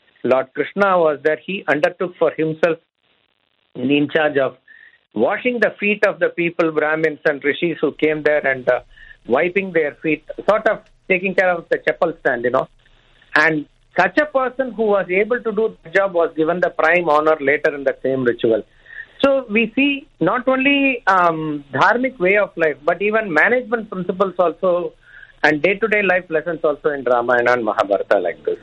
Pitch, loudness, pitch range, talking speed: 175 Hz, -18 LUFS, 155-215 Hz, 180 wpm